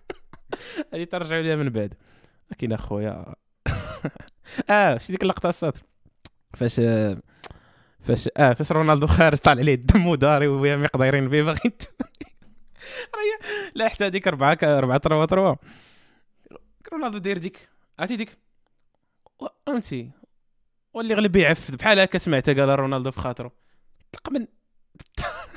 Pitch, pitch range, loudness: 155 Hz, 135-205 Hz, -22 LUFS